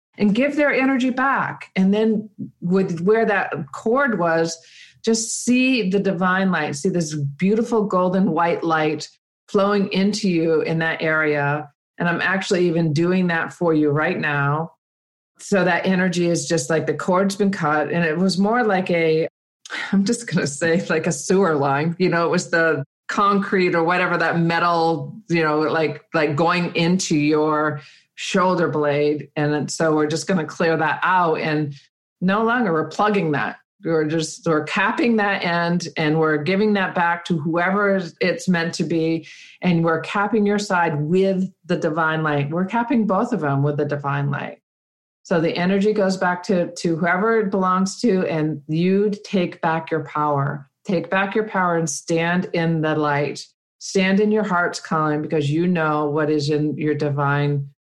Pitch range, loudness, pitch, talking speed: 155-195 Hz, -20 LUFS, 170 Hz, 175 wpm